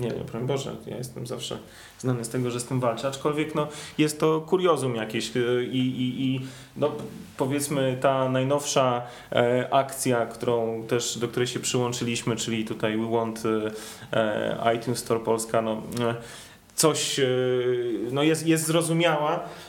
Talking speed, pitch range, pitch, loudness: 145 wpm, 115-140 Hz, 125 Hz, -26 LUFS